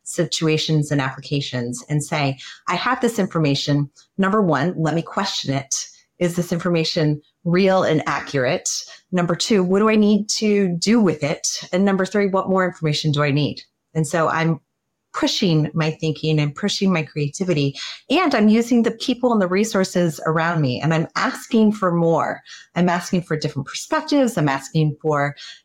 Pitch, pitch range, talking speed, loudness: 170 Hz, 150-195 Hz, 170 wpm, -20 LUFS